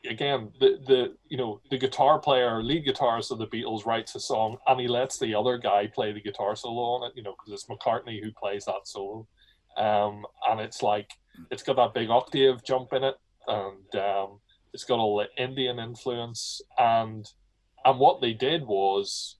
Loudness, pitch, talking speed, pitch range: -27 LUFS, 115 Hz, 195 wpm, 105-125 Hz